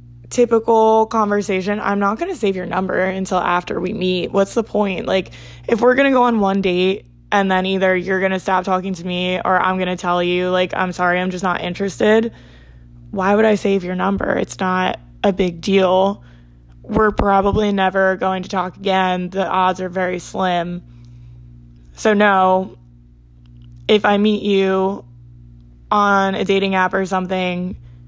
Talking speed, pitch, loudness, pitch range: 170 wpm, 185 Hz, -17 LUFS, 175-195 Hz